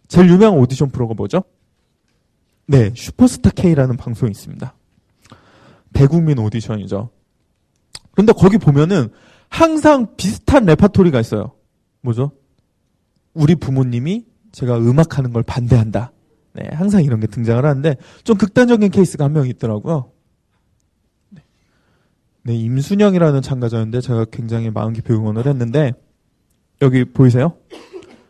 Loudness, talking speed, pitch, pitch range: -15 LUFS, 295 characters per minute, 130 Hz, 115-165 Hz